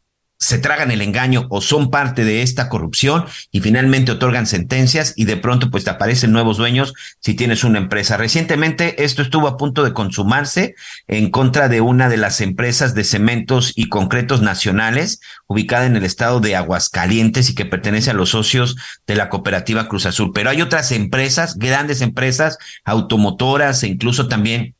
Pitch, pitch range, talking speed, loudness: 120 Hz, 105-135 Hz, 175 wpm, -15 LUFS